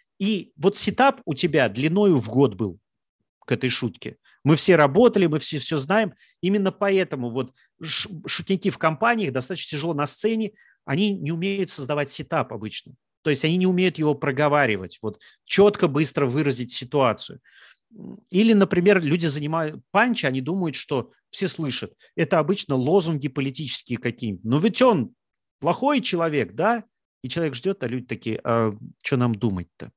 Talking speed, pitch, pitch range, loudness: 155 wpm, 155 Hz, 130-190 Hz, -22 LUFS